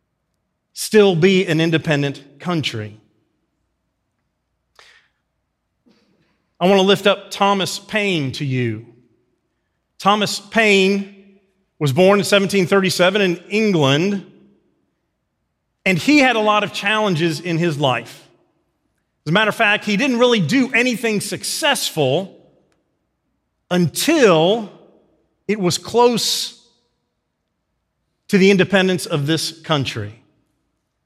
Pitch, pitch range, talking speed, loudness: 185 Hz, 155-205 Hz, 100 wpm, -17 LUFS